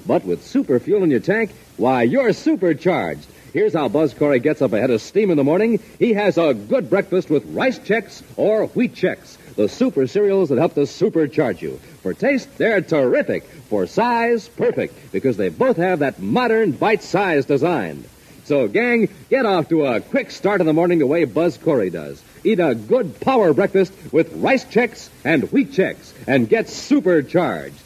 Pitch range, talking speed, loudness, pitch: 160-245 Hz, 185 wpm, -18 LUFS, 195 Hz